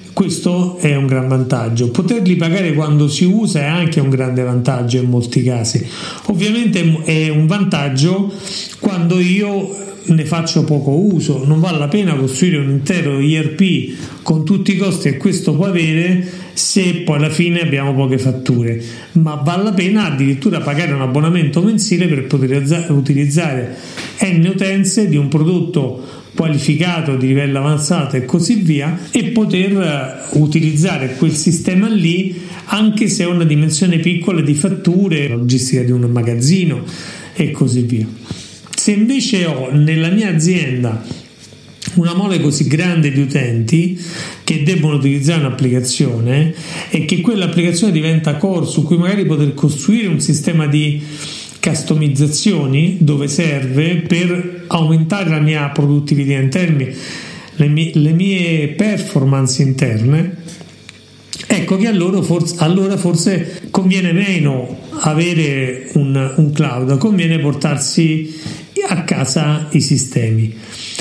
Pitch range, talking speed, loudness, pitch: 140-180 Hz, 135 wpm, -14 LUFS, 160 Hz